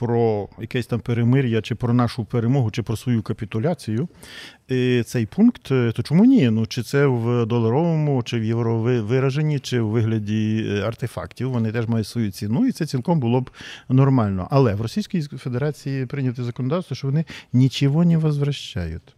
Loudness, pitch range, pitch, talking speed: -21 LUFS, 115-140 Hz, 125 Hz, 160 wpm